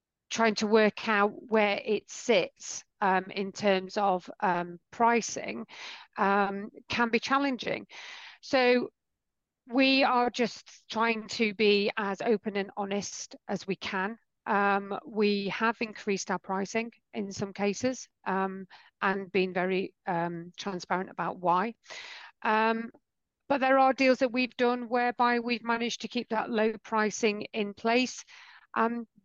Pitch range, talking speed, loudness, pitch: 200-240 Hz, 135 wpm, -29 LUFS, 220 Hz